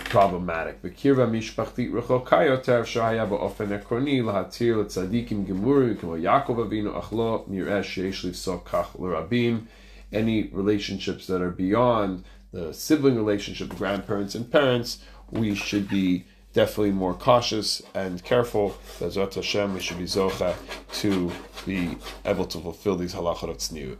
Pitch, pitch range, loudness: 100 Hz, 95-115 Hz, -25 LUFS